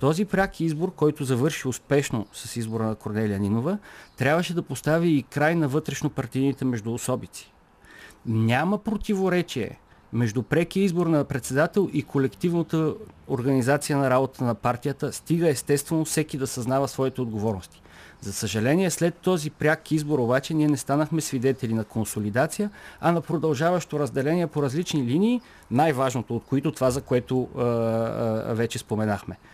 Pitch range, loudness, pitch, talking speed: 120-160 Hz, -25 LUFS, 140 Hz, 145 wpm